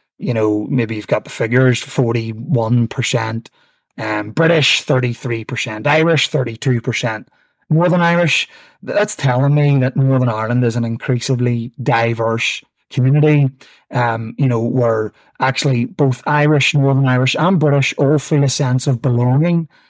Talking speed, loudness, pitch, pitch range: 130 wpm, -16 LUFS, 130 Hz, 120-145 Hz